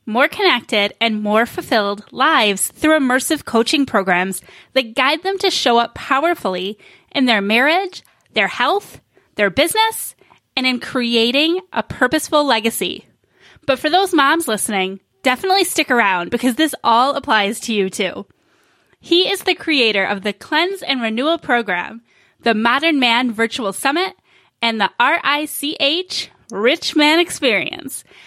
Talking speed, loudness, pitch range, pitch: 140 wpm, -16 LUFS, 220-315 Hz, 255 Hz